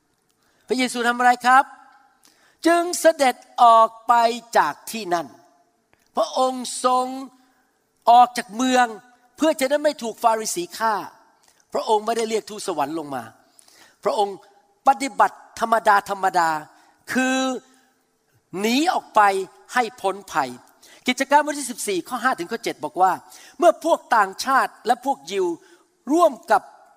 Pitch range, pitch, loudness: 210-270 Hz, 245 Hz, -21 LUFS